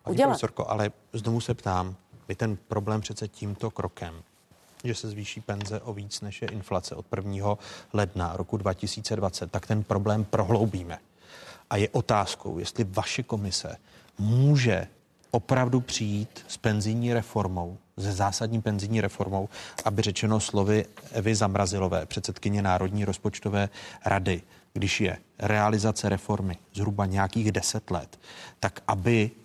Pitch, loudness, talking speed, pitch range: 105 Hz, -28 LUFS, 130 wpm, 95-110 Hz